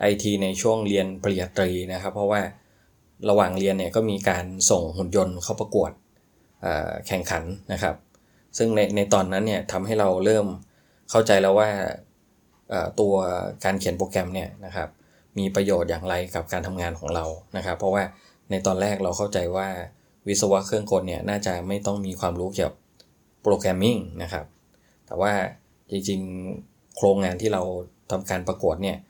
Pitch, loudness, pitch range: 95 Hz, -25 LUFS, 95-100 Hz